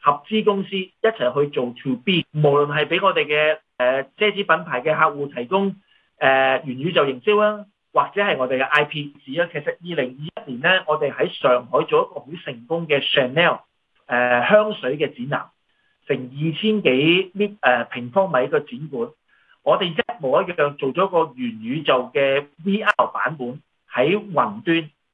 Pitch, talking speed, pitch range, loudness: 160 Hz, 265 characters per minute, 140-205 Hz, -20 LUFS